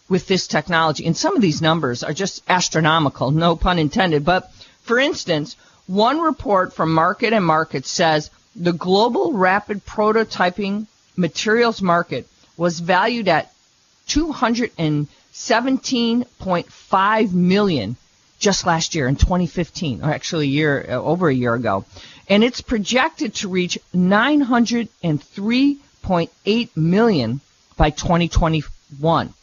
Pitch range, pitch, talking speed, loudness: 155-215 Hz, 180 Hz, 140 wpm, -19 LUFS